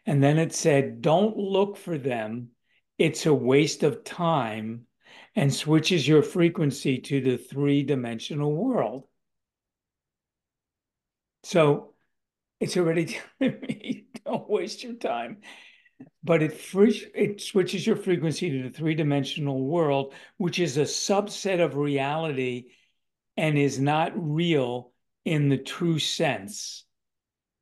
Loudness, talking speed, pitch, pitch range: -25 LUFS, 125 wpm, 155 Hz, 140-185 Hz